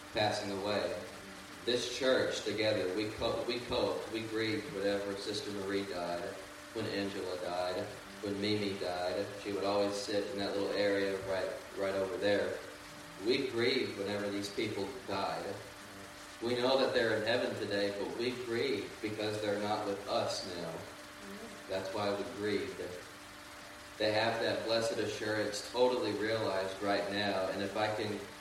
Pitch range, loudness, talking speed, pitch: 100-105 Hz, -35 LUFS, 150 wpm, 100 Hz